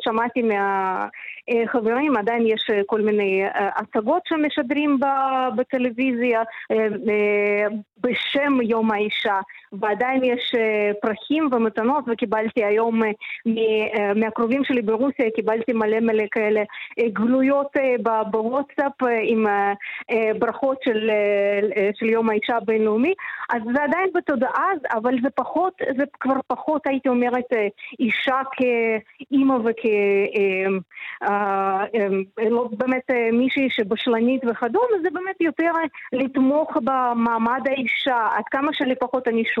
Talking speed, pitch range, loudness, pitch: 105 wpm, 220-265 Hz, -21 LUFS, 235 Hz